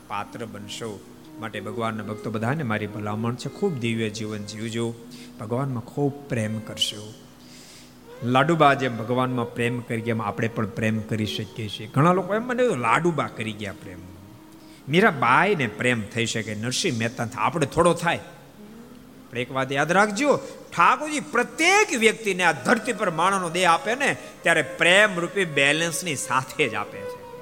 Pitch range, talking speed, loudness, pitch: 110-175 Hz, 150 wpm, -23 LUFS, 125 Hz